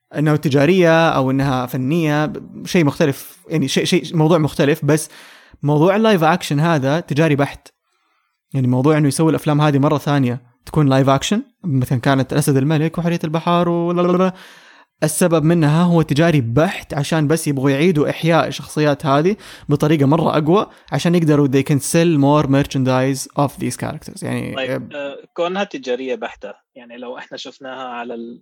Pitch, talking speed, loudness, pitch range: 150 Hz, 150 wpm, -17 LUFS, 140-165 Hz